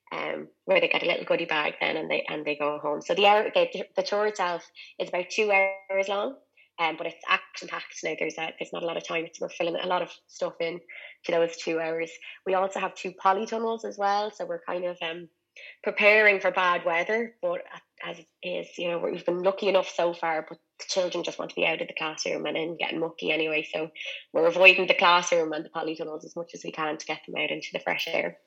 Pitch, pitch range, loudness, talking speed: 175 Hz, 165-195 Hz, -26 LUFS, 245 wpm